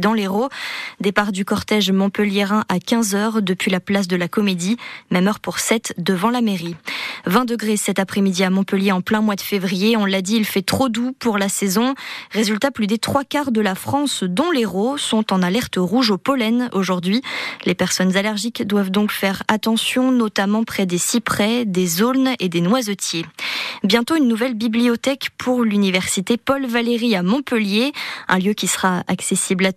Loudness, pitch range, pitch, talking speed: -19 LUFS, 195-235 Hz, 215 Hz, 180 wpm